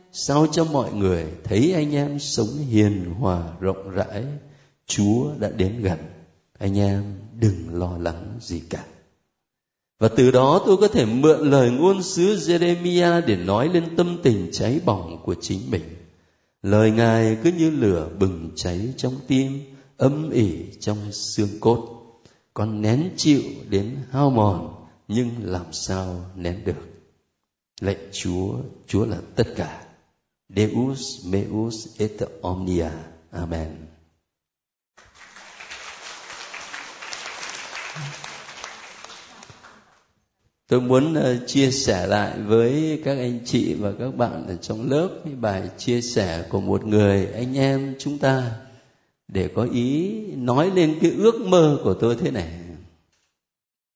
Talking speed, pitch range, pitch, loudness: 130 wpm, 95-135 Hz, 110 Hz, -22 LUFS